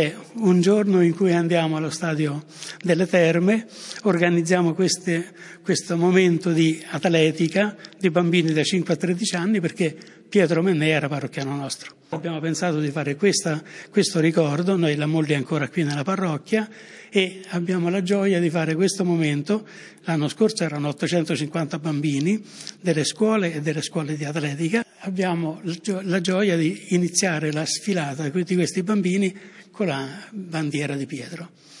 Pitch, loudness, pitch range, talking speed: 170 Hz, -22 LUFS, 155-190 Hz, 145 wpm